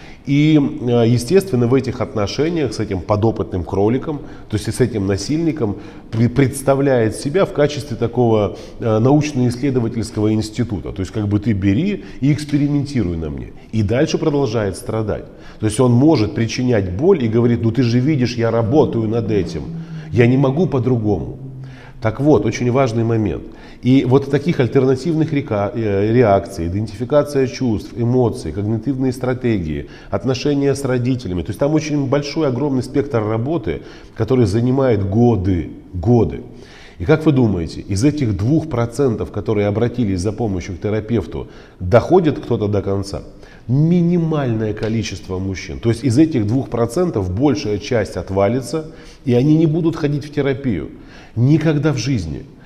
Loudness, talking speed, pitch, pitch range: -17 LUFS, 140 wpm, 120 Hz, 105-140 Hz